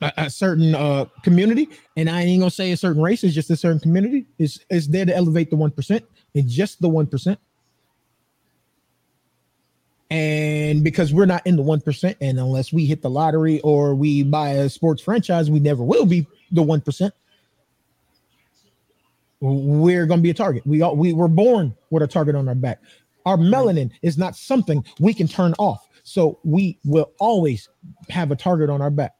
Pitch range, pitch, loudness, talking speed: 145-180 Hz, 160 Hz, -19 LUFS, 190 wpm